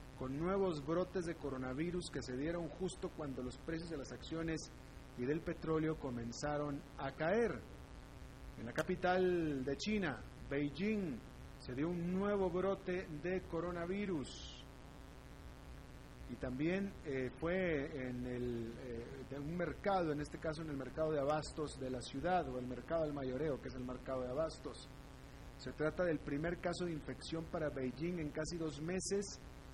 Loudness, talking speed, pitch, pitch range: -41 LUFS, 160 wpm, 155 Hz, 135-175 Hz